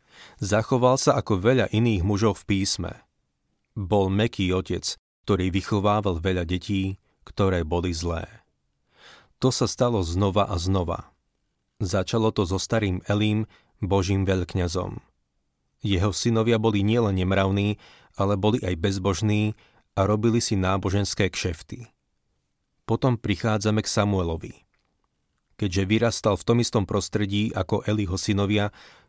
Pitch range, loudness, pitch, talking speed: 95-110 Hz, -24 LUFS, 100 Hz, 120 wpm